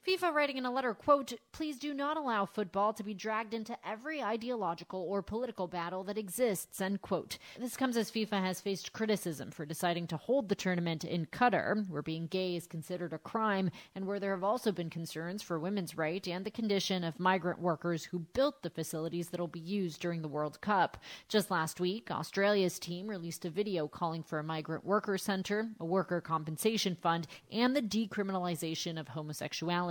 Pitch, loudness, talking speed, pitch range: 185 Hz, -35 LUFS, 195 wpm, 170-215 Hz